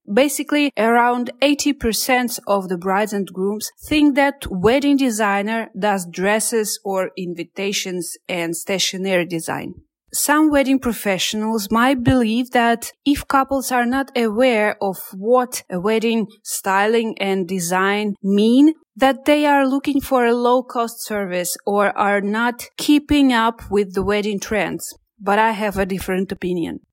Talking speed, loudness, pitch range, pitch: 135 wpm, -19 LUFS, 195-255 Hz, 220 Hz